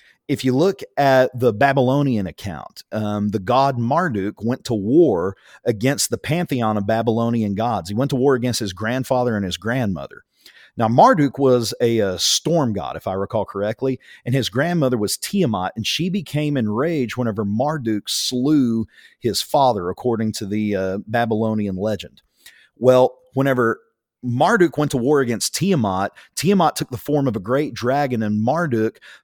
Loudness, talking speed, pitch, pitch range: -20 LUFS, 160 wpm, 120 Hz, 110-135 Hz